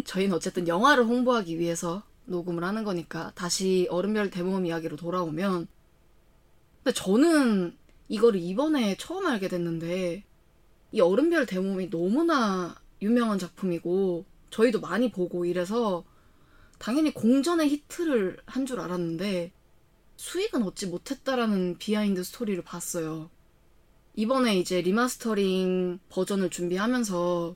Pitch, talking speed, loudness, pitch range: 190 Hz, 305 characters per minute, -27 LUFS, 175-235 Hz